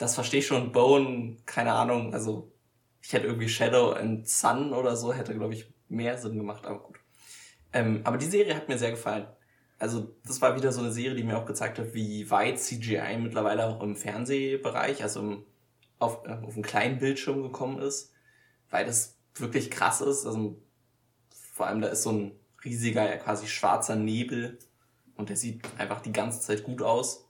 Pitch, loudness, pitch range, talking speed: 115 Hz, -29 LUFS, 110-125 Hz, 185 wpm